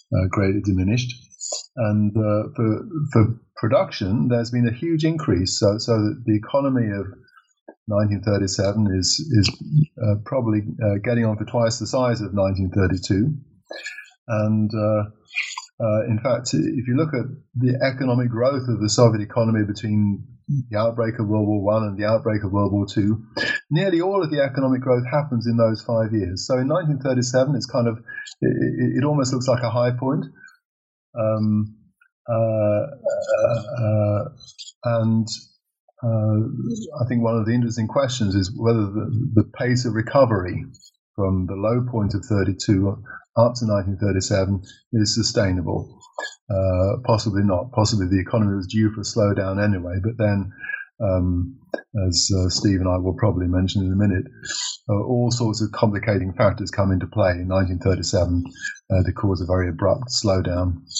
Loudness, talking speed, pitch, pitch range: -22 LUFS, 160 wpm, 110 Hz, 100-120 Hz